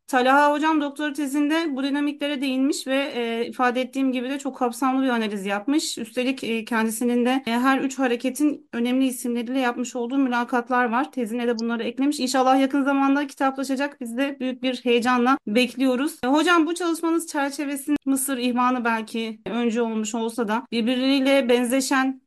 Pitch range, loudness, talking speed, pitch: 240-280 Hz, -23 LUFS, 165 wpm, 260 Hz